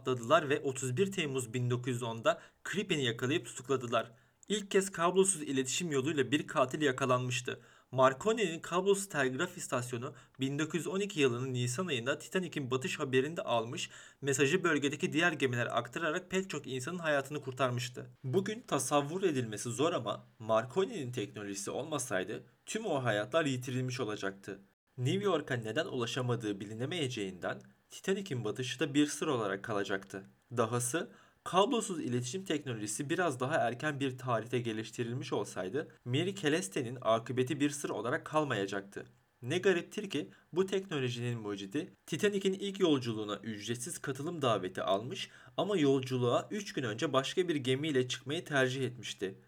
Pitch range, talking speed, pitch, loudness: 125-165 Hz, 125 wpm, 135 Hz, -34 LUFS